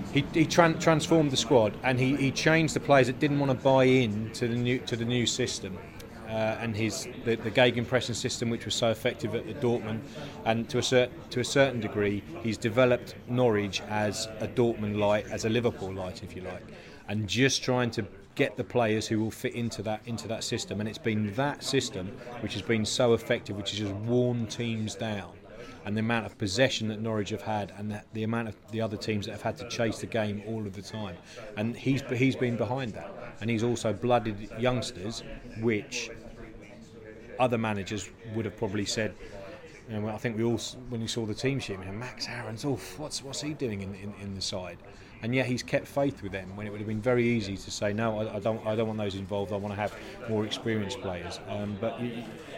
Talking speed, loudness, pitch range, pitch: 225 wpm, -29 LUFS, 105-125 Hz, 115 Hz